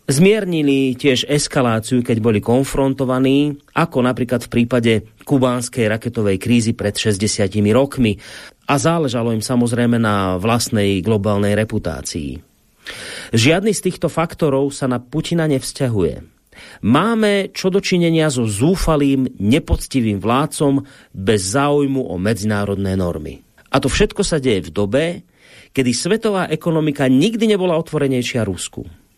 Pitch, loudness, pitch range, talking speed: 130 Hz, -17 LUFS, 110-155 Hz, 120 wpm